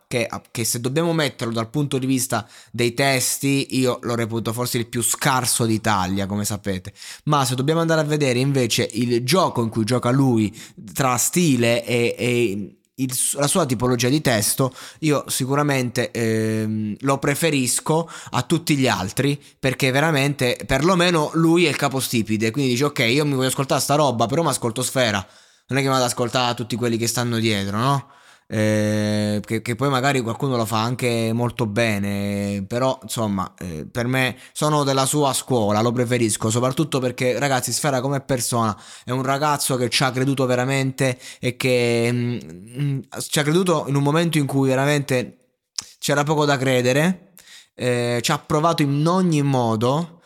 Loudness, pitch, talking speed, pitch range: -20 LUFS, 130 Hz, 175 wpm, 115-140 Hz